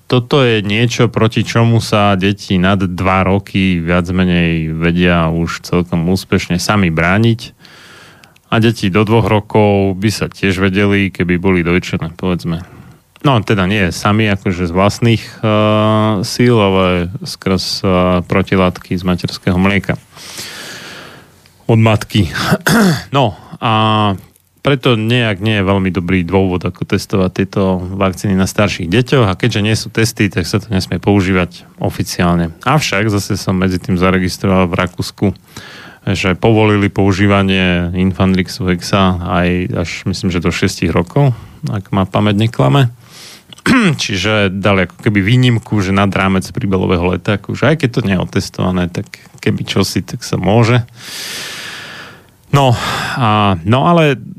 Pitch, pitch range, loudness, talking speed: 100 Hz, 90-110 Hz, -13 LUFS, 140 wpm